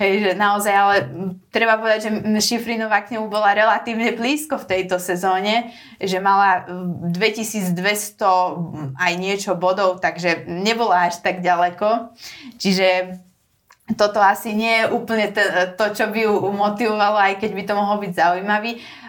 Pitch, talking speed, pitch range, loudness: 205 Hz, 140 wpm, 185-220 Hz, -19 LUFS